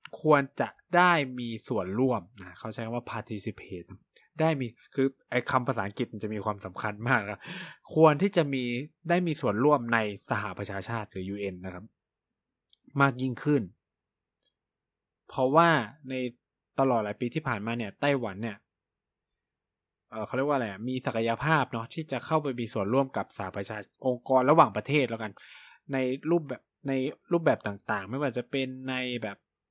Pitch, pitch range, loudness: 125 Hz, 105-140 Hz, -29 LUFS